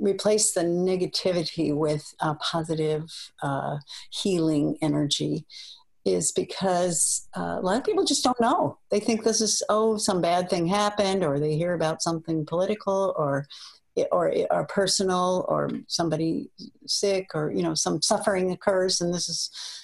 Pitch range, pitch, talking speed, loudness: 160-205 Hz, 180 Hz, 150 wpm, -25 LUFS